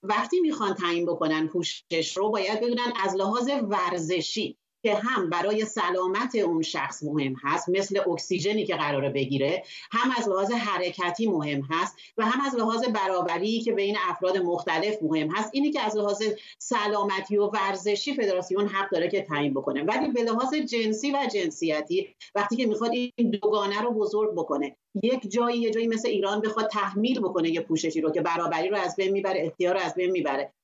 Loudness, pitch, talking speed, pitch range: -27 LUFS, 205 Hz, 180 wpm, 175-230 Hz